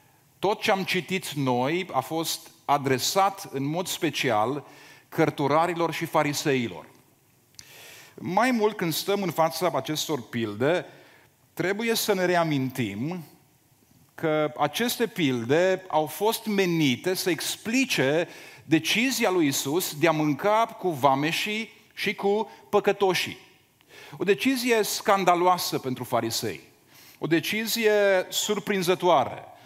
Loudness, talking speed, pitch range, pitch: -25 LUFS, 105 wpm, 145-200 Hz, 170 Hz